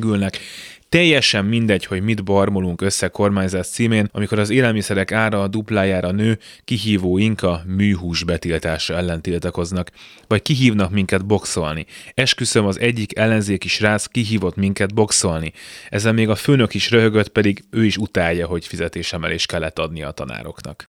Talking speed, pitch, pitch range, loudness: 145 wpm, 100 Hz, 90-110 Hz, -18 LUFS